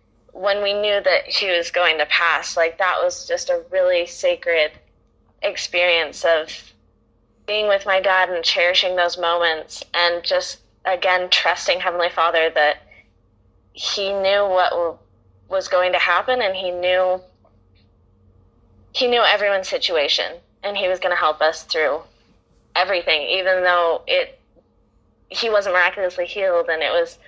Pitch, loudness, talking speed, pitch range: 180 Hz, -19 LUFS, 145 wpm, 155-195 Hz